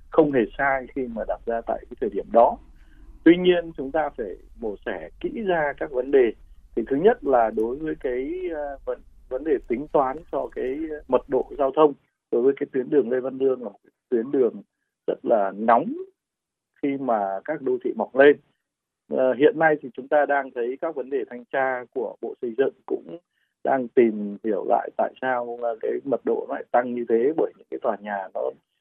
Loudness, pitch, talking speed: -24 LUFS, 140 Hz, 210 wpm